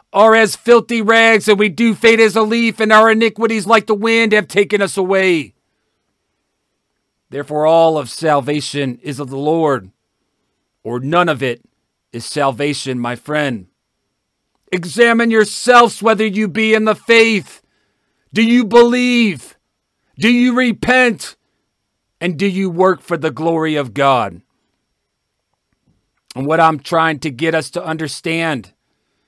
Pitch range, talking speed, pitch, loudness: 145-225 Hz, 140 wpm, 175 Hz, -13 LUFS